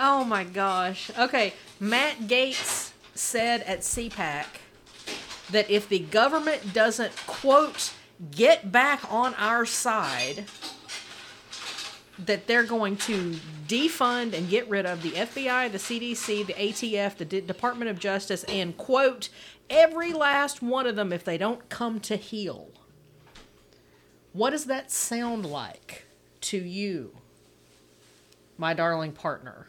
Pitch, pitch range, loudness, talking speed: 210 Hz, 180-240 Hz, -26 LUFS, 125 wpm